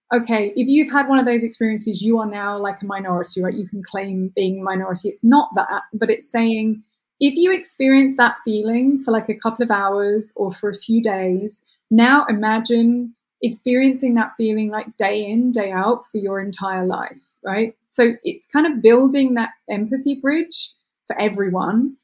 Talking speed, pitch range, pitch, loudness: 180 wpm, 205-250 Hz, 225 Hz, -19 LUFS